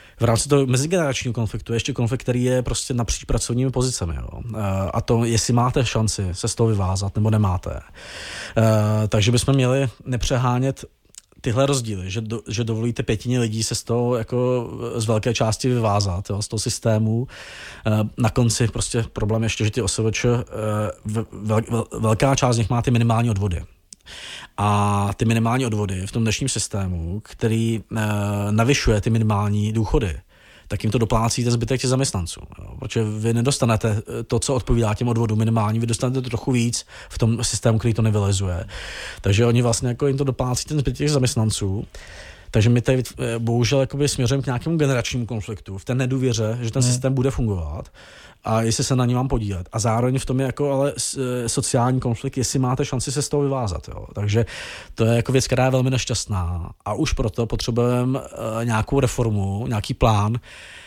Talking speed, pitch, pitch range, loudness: 180 wpm, 115 Hz, 110-125 Hz, -21 LUFS